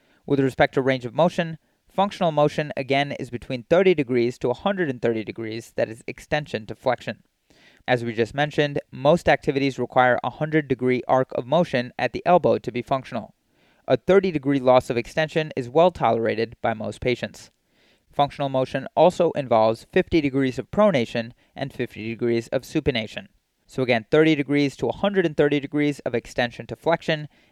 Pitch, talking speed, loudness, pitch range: 135 Hz, 165 wpm, -23 LUFS, 120-155 Hz